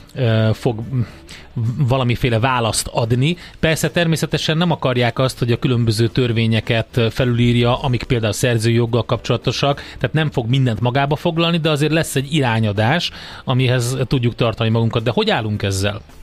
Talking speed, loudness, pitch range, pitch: 140 wpm, -18 LUFS, 115-140 Hz, 125 Hz